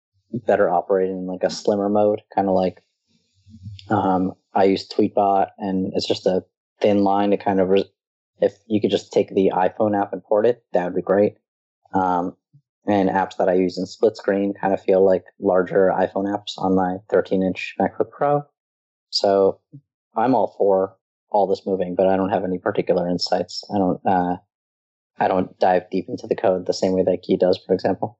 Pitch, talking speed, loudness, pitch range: 95 Hz, 195 wpm, -21 LUFS, 95-100 Hz